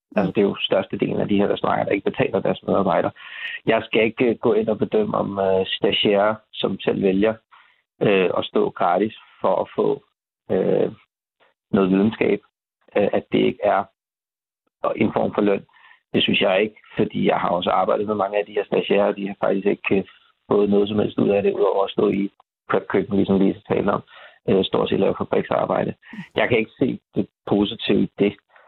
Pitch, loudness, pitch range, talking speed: 100 Hz, -21 LUFS, 100-105 Hz, 210 wpm